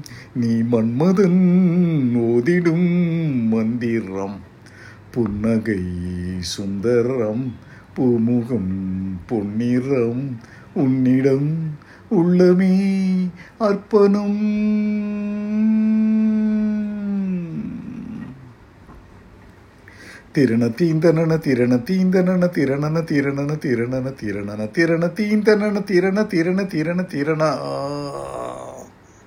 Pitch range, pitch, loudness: 115-185 Hz, 140 Hz, -19 LUFS